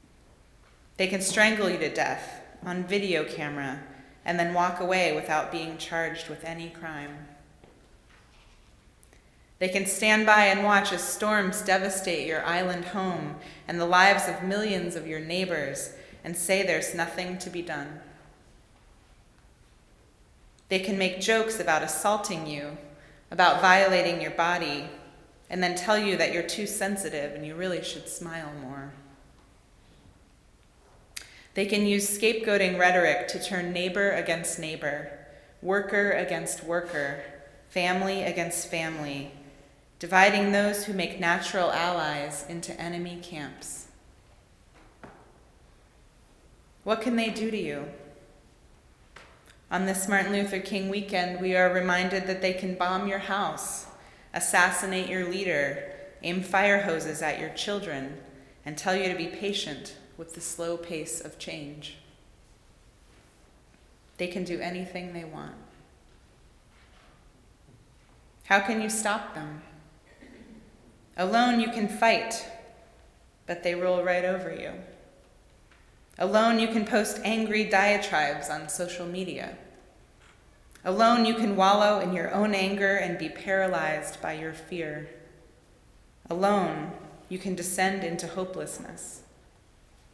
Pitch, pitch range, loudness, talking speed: 180 Hz, 155-195 Hz, -27 LUFS, 125 wpm